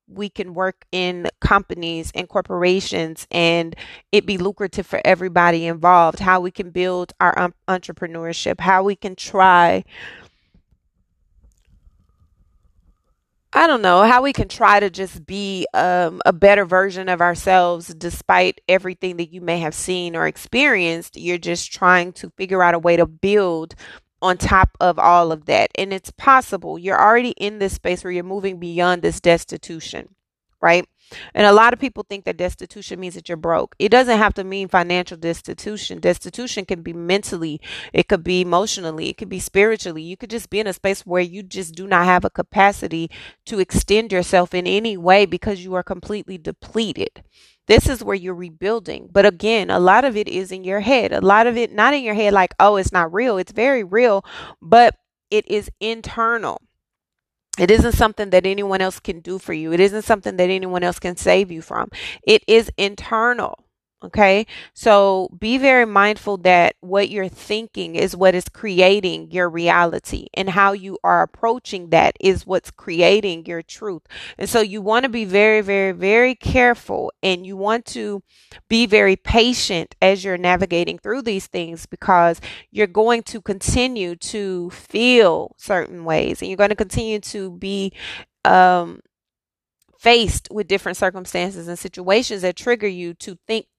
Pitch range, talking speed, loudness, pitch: 175-205 Hz, 175 wpm, -17 LUFS, 190 Hz